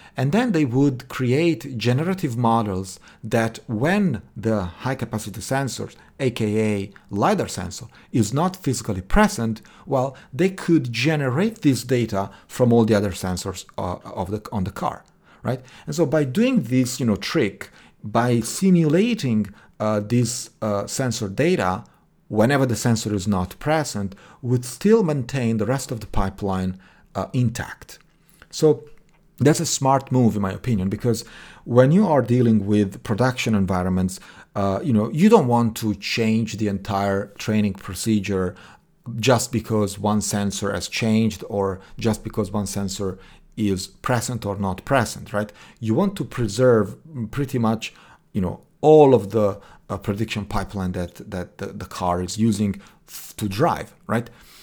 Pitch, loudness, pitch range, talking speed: 115 Hz, -22 LUFS, 100-135 Hz, 150 wpm